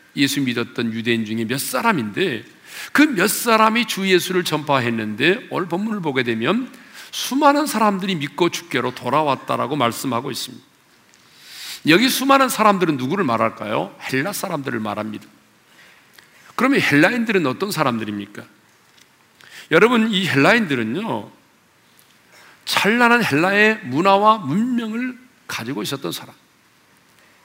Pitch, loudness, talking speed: 180 Hz, -18 LUFS, 295 characters per minute